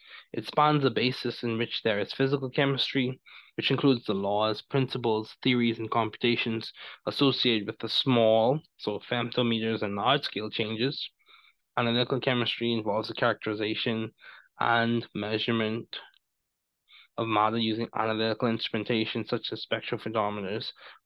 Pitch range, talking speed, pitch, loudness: 110-130 Hz, 125 wpm, 115 Hz, -28 LUFS